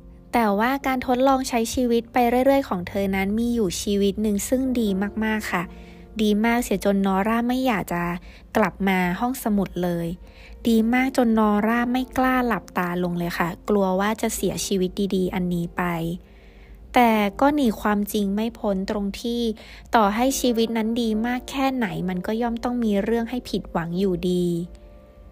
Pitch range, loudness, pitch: 185-240 Hz, -23 LUFS, 215 Hz